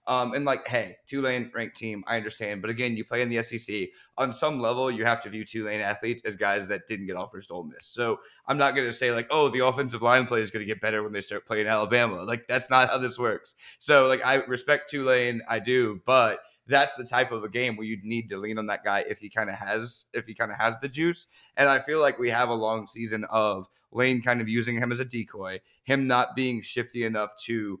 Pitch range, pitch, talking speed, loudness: 110-125 Hz, 115 Hz, 255 wpm, -26 LUFS